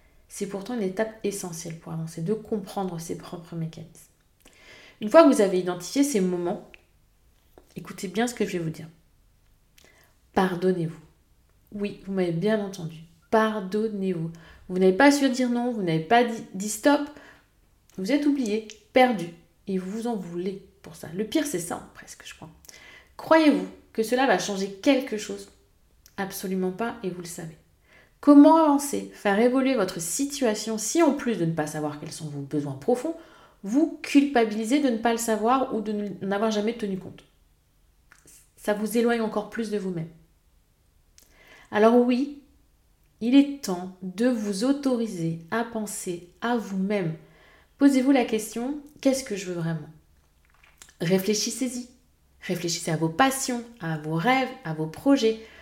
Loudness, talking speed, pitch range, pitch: -25 LUFS, 160 wpm, 170-245 Hz, 205 Hz